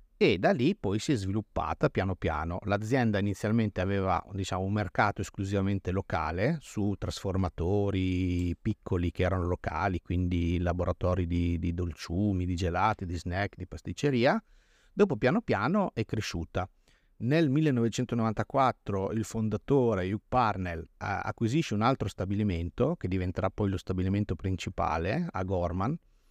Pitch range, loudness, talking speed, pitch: 90-110 Hz, -30 LUFS, 130 wpm, 100 Hz